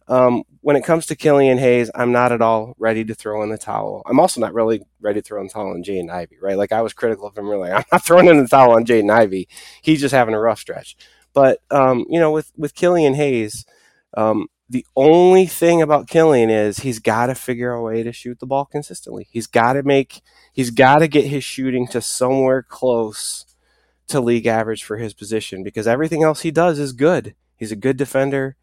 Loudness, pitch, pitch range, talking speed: -17 LUFS, 125 Hz, 110-140 Hz, 235 wpm